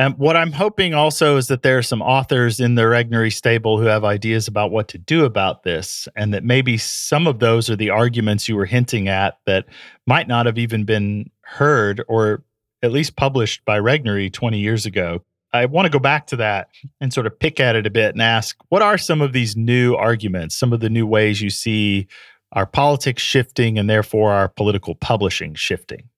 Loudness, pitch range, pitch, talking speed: -18 LUFS, 105-130 Hz, 115 Hz, 215 wpm